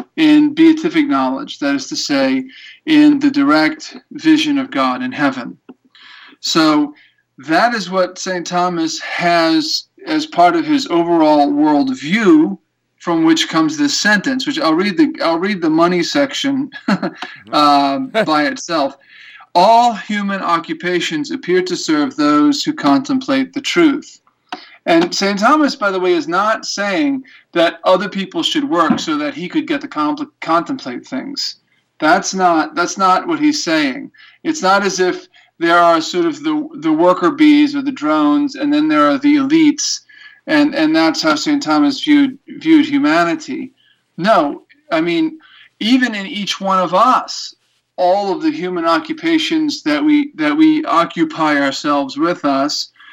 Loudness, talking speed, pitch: -15 LUFS, 155 wpm, 280 Hz